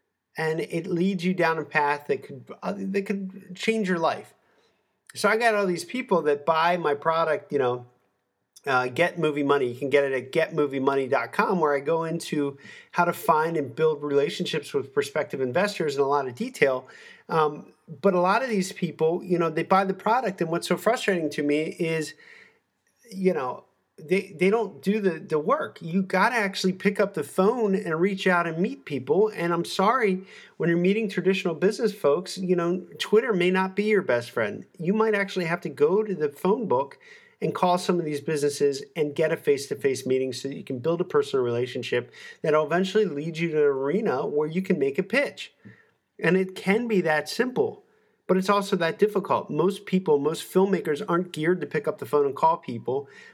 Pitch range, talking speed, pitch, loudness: 155-200 Hz, 205 wpm, 180 Hz, -25 LUFS